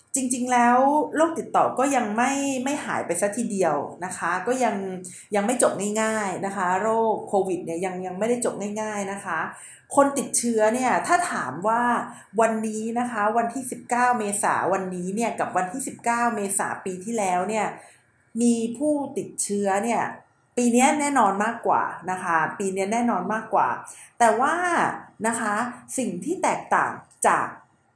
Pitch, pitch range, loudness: 225 Hz, 195-245 Hz, -24 LUFS